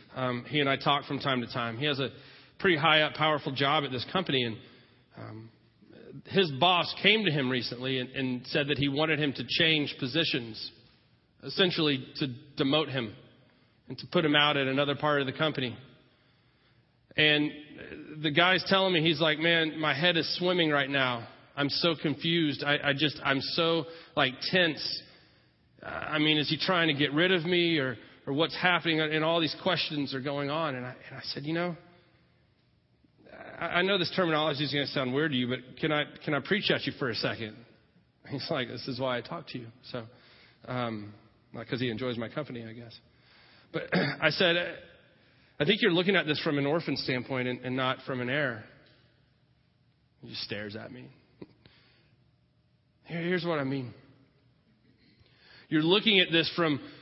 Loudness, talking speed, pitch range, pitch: -28 LUFS, 190 wpm, 125-160 Hz, 145 Hz